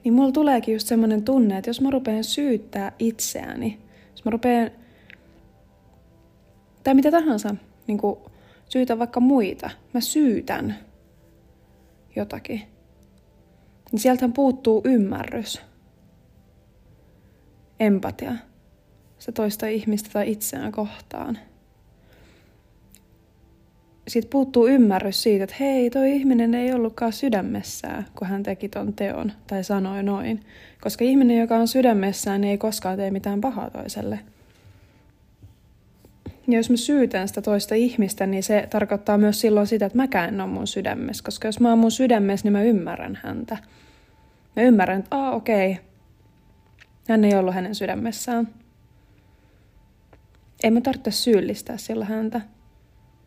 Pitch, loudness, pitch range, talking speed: 220 Hz, -22 LUFS, 200-245 Hz, 125 wpm